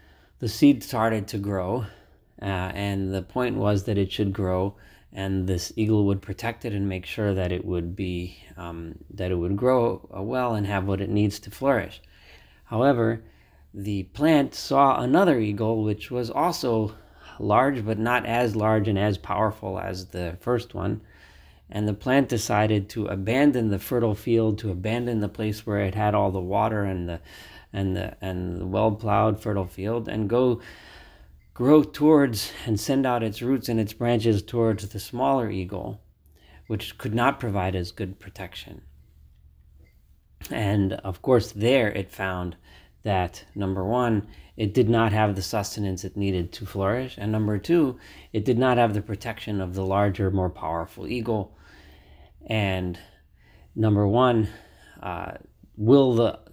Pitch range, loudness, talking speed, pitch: 95-115 Hz, -25 LUFS, 160 wpm, 105 Hz